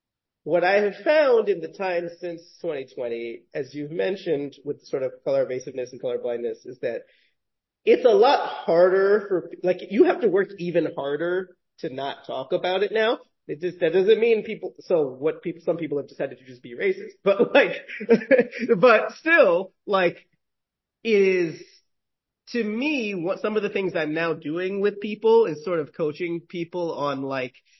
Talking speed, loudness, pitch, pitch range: 180 wpm, -23 LUFS, 190 Hz, 165-275 Hz